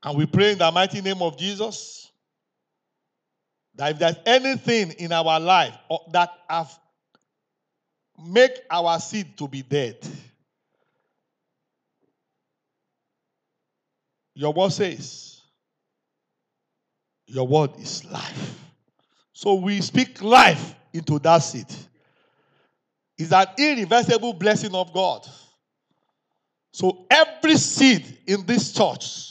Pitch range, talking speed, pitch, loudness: 165-225 Hz, 100 wpm, 185 Hz, -20 LUFS